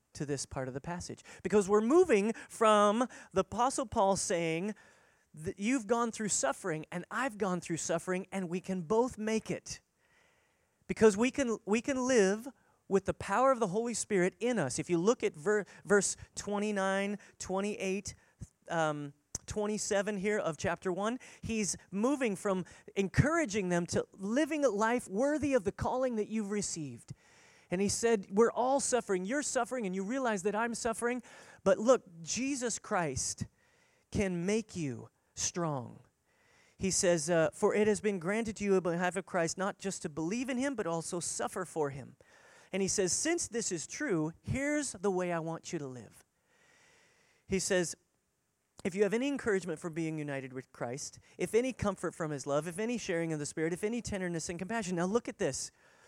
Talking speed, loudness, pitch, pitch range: 180 wpm, -33 LUFS, 200 Hz, 175-230 Hz